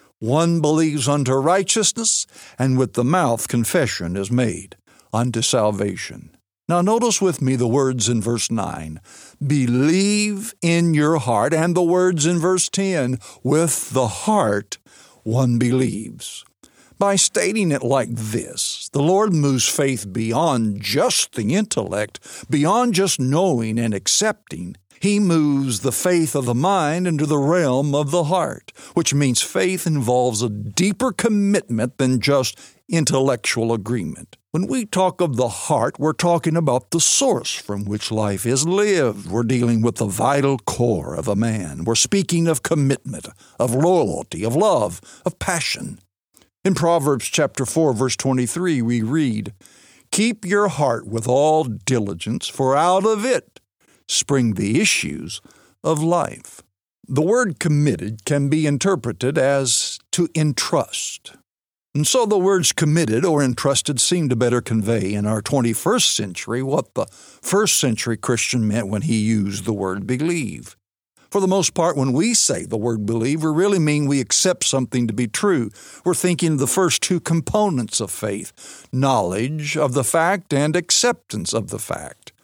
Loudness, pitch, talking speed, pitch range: -19 LUFS, 140 Hz, 155 wpm, 115-170 Hz